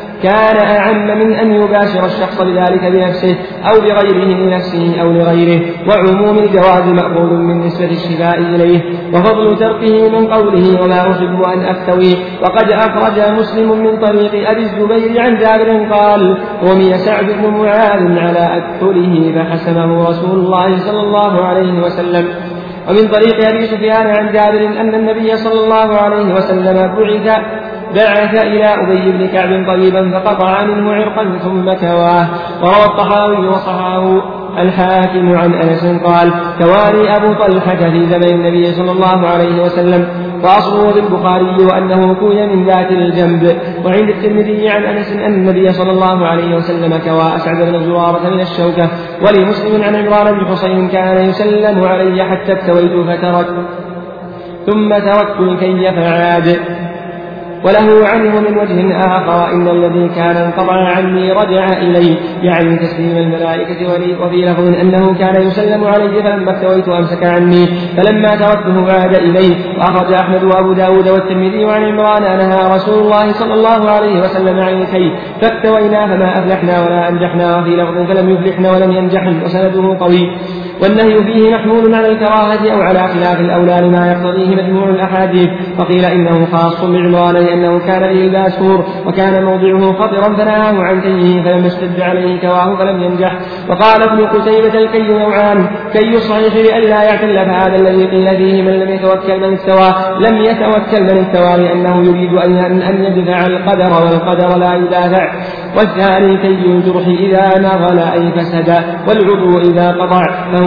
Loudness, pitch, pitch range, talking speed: -10 LUFS, 185 Hz, 175-205 Hz, 140 wpm